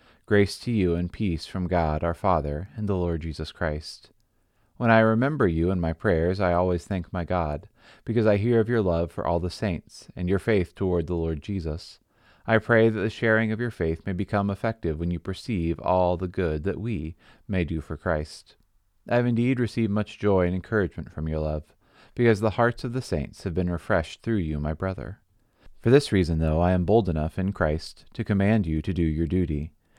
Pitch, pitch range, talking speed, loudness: 95 Hz, 85-110 Hz, 215 wpm, -25 LUFS